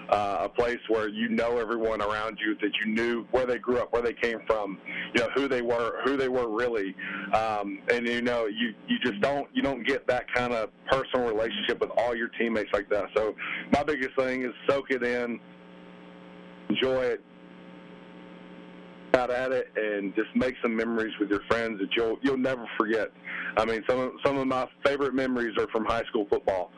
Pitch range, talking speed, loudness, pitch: 105-130 Hz, 205 wpm, -28 LUFS, 115 Hz